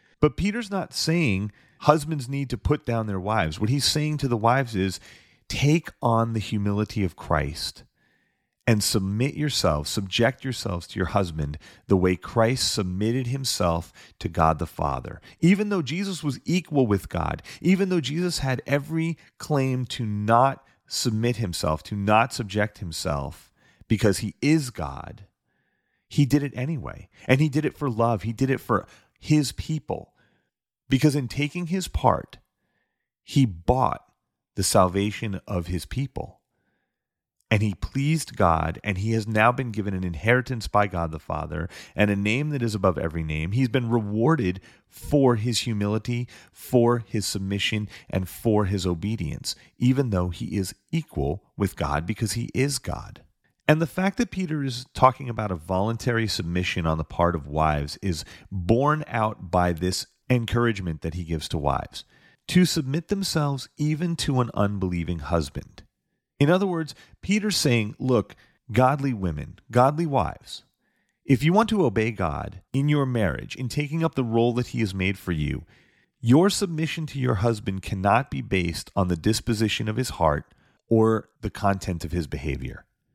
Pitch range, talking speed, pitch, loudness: 95-135 Hz, 165 wpm, 115 Hz, -25 LUFS